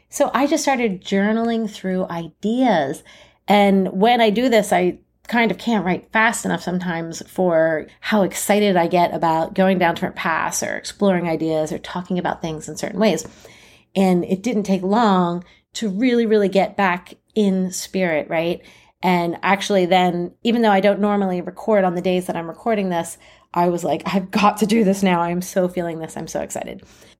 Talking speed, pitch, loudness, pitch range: 190 wpm, 190 Hz, -19 LUFS, 175-210 Hz